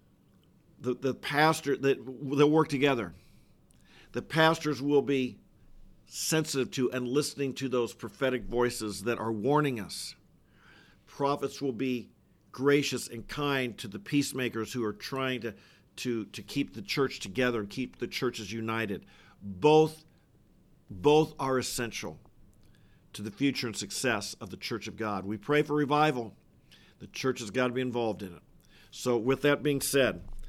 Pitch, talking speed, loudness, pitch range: 130 Hz, 155 wpm, -30 LUFS, 115-140 Hz